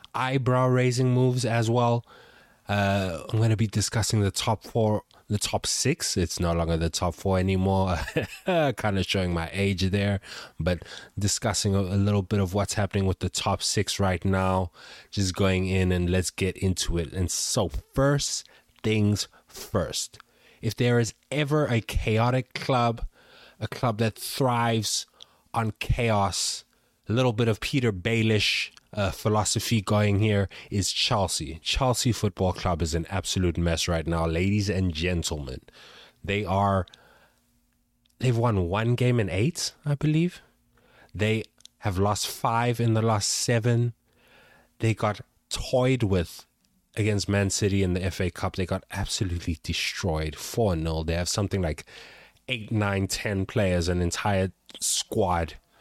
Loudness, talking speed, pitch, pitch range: -26 LUFS, 150 wpm, 100 Hz, 95-115 Hz